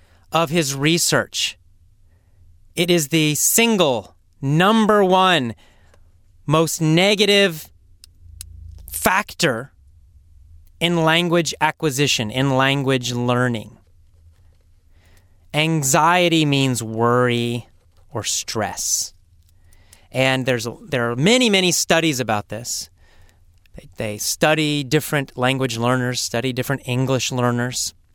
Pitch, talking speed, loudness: 120 Hz, 90 wpm, -18 LUFS